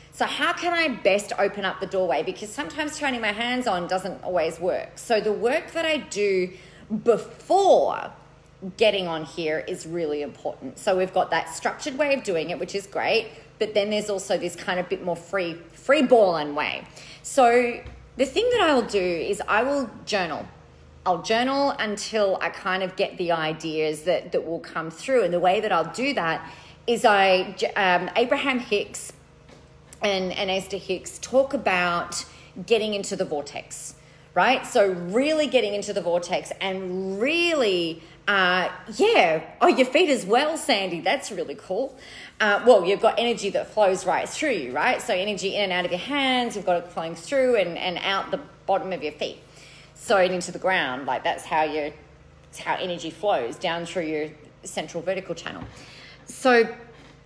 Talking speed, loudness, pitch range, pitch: 180 wpm, -24 LUFS, 170-235 Hz, 190 Hz